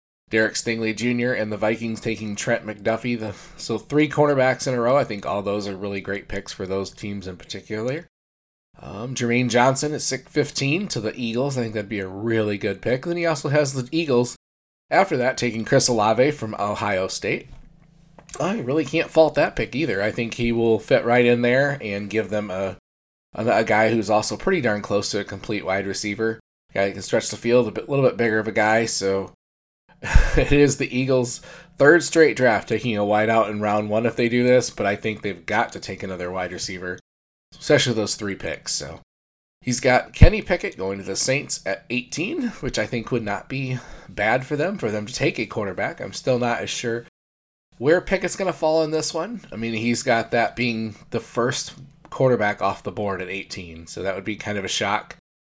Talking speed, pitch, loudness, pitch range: 220 wpm, 110 Hz, -22 LUFS, 100-125 Hz